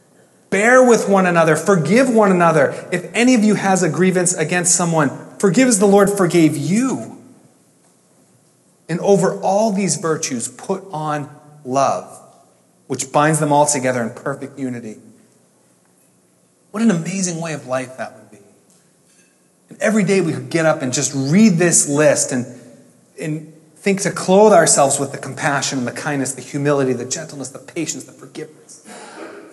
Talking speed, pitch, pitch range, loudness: 160 wpm, 160 Hz, 140-195 Hz, -16 LUFS